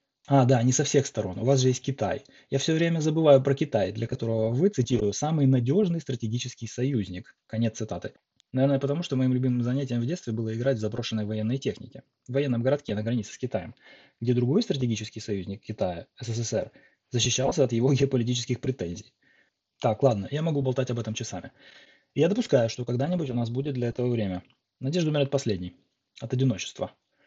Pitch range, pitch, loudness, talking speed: 115-140 Hz, 125 Hz, -27 LUFS, 185 wpm